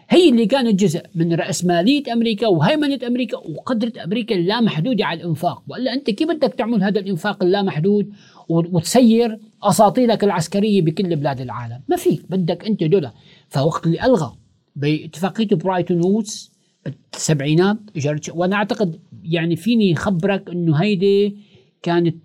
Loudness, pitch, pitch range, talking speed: -18 LUFS, 195 Hz, 170-220 Hz, 130 wpm